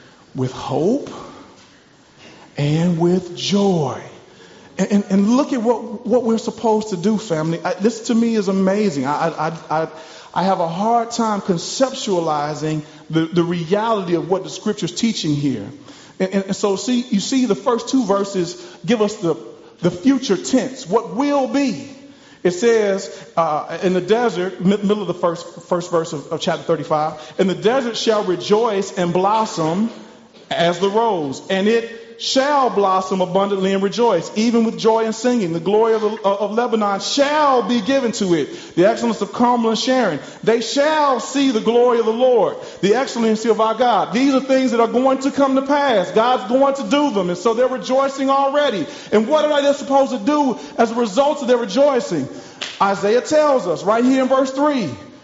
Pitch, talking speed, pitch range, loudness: 220 Hz, 185 wpm, 185-255 Hz, -18 LUFS